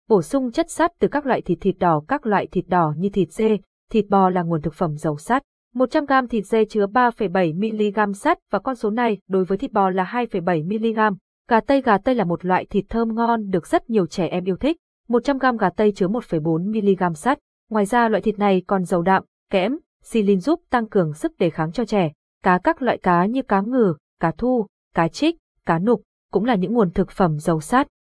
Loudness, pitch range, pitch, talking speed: -21 LUFS, 185-245 Hz, 210 Hz, 220 wpm